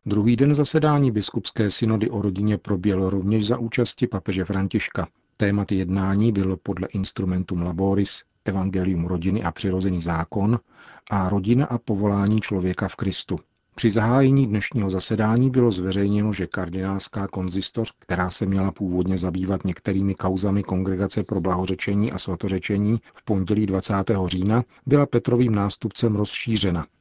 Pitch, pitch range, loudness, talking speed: 100 Hz, 95-110 Hz, -23 LUFS, 135 wpm